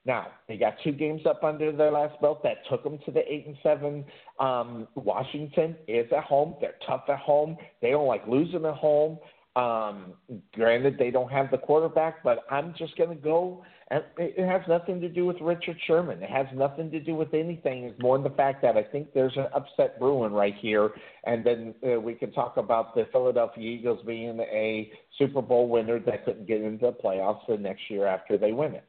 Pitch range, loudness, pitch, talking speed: 120-160 Hz, -27 LUFS, 145 Hz, 215 wpm